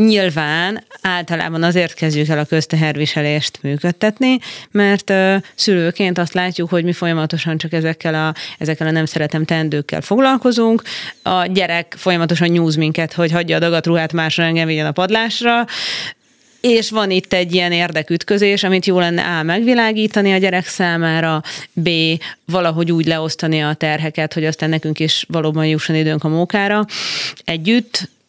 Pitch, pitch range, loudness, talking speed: 170 Hz, 160-190 Hz, -16 LUFS, 145 wpm